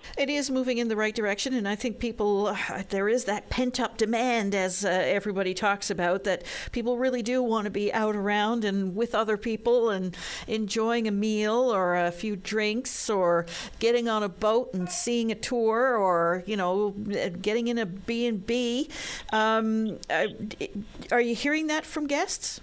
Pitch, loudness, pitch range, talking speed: 220 Hz, -27 LUFS, 200-240 Hz, 180 wpm